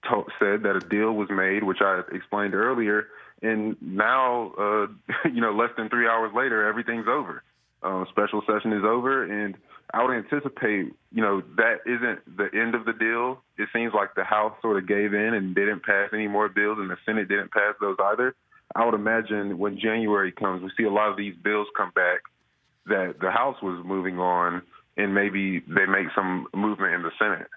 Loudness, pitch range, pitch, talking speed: -25 LUFS, 100-115 Hz, 105 Hz, 200 wpm